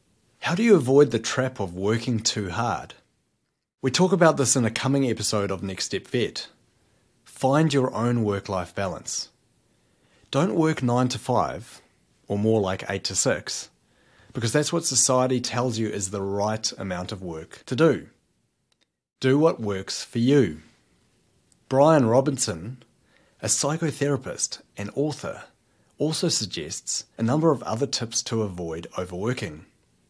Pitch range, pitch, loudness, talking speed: 105-135 Hz, 120 Hz, -24 LUFS, 150 wpm